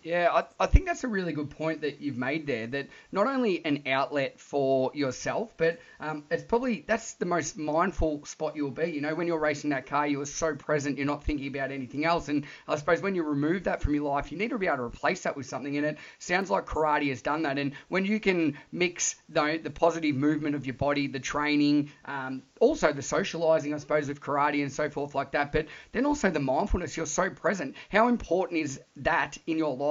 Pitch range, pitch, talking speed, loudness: 145-170 Hz, 150 Hz, 235 wpm, -29 LUFS